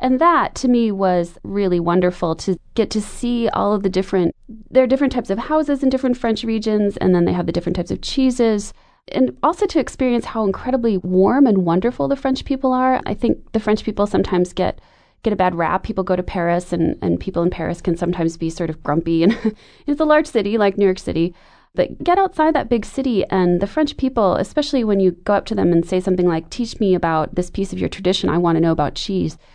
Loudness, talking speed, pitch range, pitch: -19 LUFS, 240 wpm, 180-255 Hz, 205 Hz